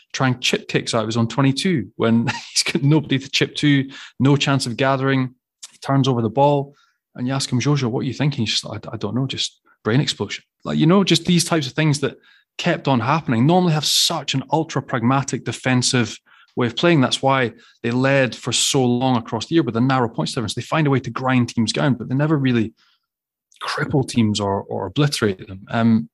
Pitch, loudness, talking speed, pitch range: 130 Hz, -19 LUFS, 225 wpm, 120-145 Hz